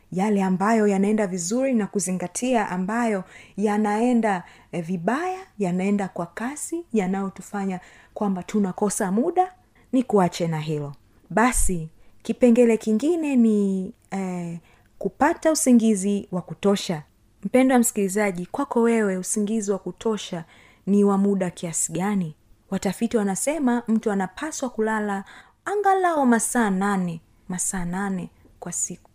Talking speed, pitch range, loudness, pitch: 110 wpm, 185-230 Hz, -23 LUFS, 200 Hz